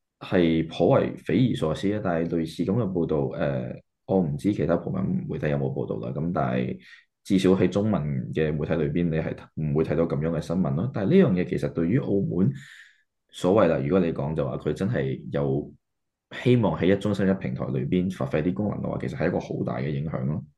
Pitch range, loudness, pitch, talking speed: 75-95 Hz, -25 LUFS, 80 Hz, 320 characters per minute